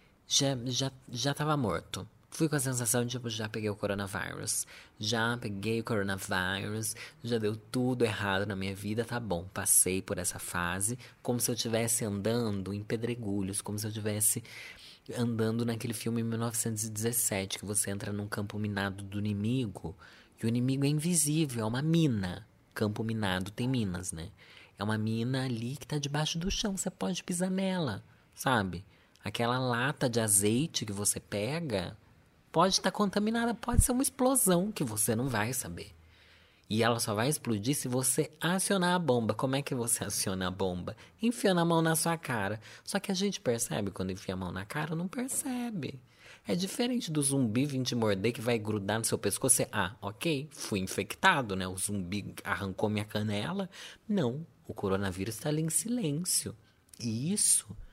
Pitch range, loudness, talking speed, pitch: 100-145 Hz, -31 LUFS, 180 wpm, 115 Hz